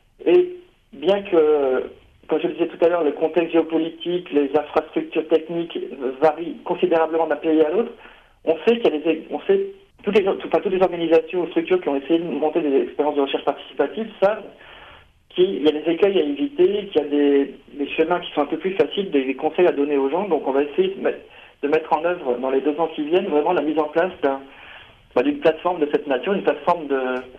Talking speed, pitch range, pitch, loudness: 230 wpm, 145-185 Hz, 160 Hz, -21 LUFS